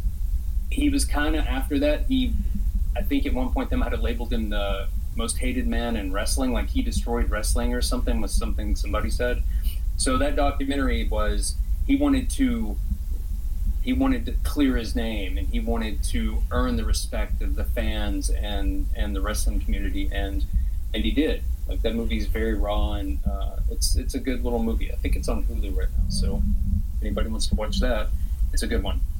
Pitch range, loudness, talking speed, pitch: 70-105 Hz, -27 LUFS, 200 wpm, 75 Hz